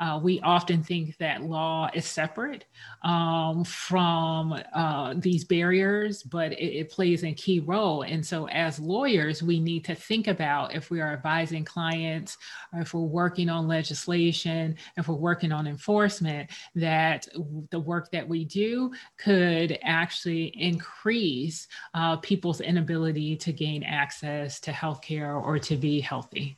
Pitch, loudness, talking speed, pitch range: 165 Hz, -27 LUFS, 155 wpm, 155-175 Hz